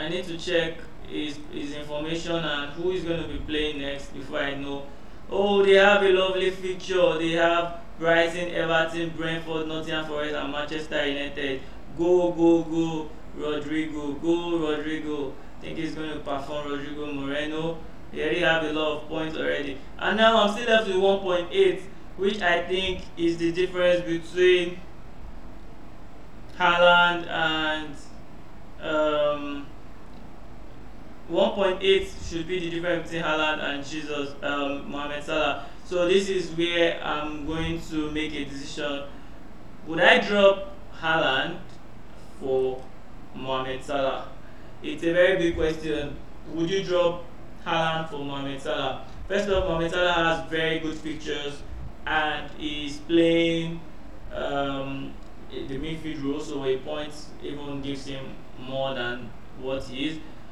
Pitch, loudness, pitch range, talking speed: 155 Hz, -25 LUFS, 145-170 Hz, 145 wpm